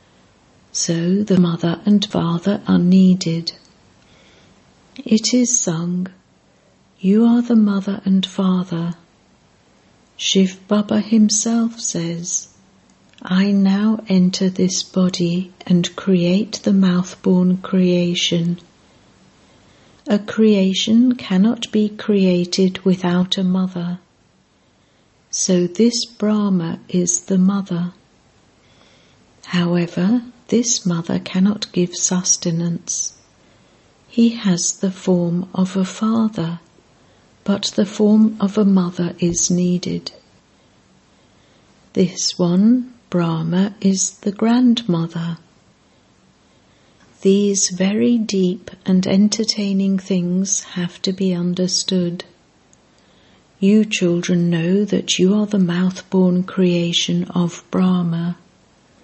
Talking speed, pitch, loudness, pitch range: 95 wpm, 185 Hz, -18 LUFS, 175-205 Hz